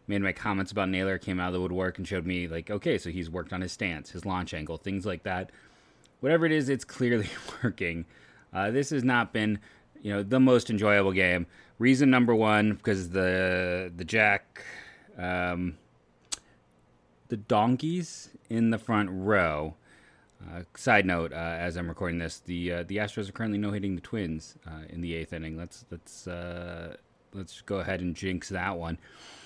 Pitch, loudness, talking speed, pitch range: 95 Hz, -29 LUFS, 185 wpm, 85-105 Hz